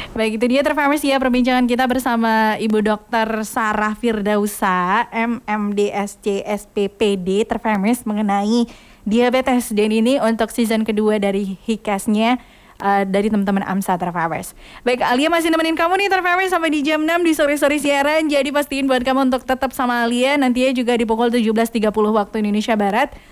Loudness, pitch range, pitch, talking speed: -18 LUFS, 210-265 Hz, 230 Hz, 150 wpm